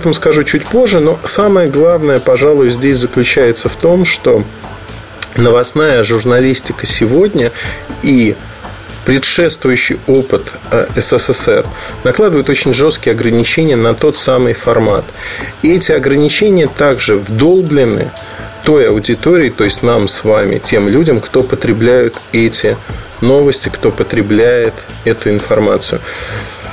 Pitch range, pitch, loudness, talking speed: 110-150 Hz, 120 Hz, -10 LUFS, 110 wpm